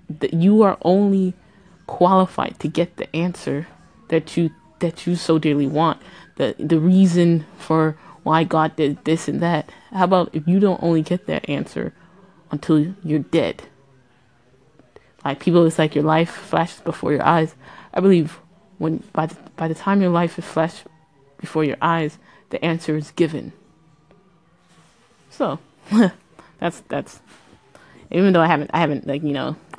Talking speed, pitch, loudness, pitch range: 155 wpm, 165 Hz, -20 LUFS, 155-180 Hz